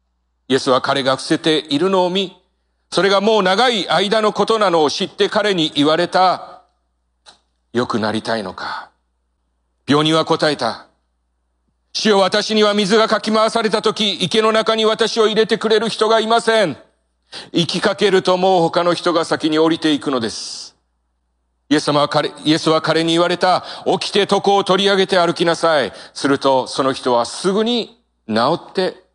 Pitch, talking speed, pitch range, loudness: 175 Hz, 295 characters per minute, 130-210 Hz, -16 LUFS